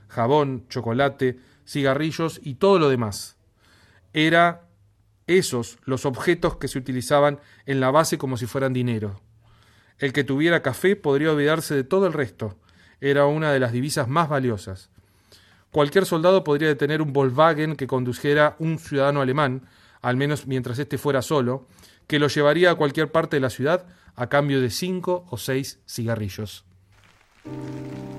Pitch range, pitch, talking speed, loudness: 110-150 Hz, 135 Hz, 150 wpm, -22 LUFS